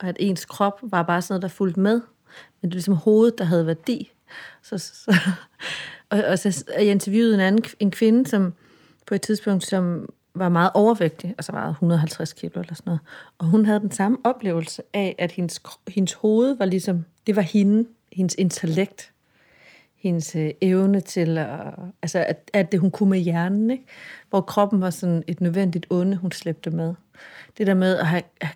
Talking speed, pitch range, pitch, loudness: 195 wpm, 170-205 Hz, 190 Hz, -22 LUFS